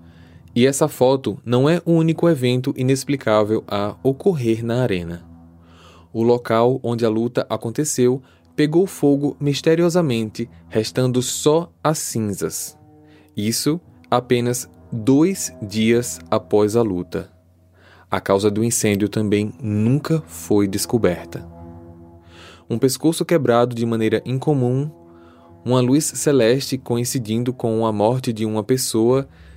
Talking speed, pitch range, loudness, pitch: 115 wpm, 100-135 Hz, -19 LUFS, 115 Hz